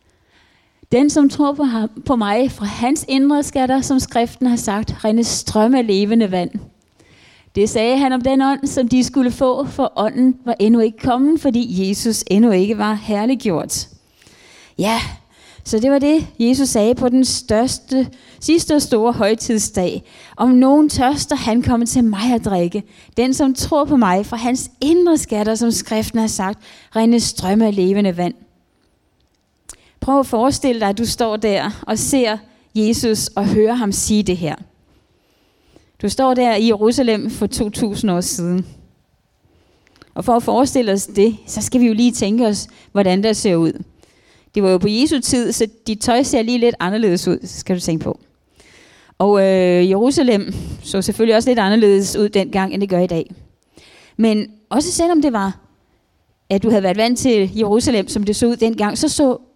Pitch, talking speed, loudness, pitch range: 225 Hz, 175 wpm, -16 LUFS, 205-255 Hz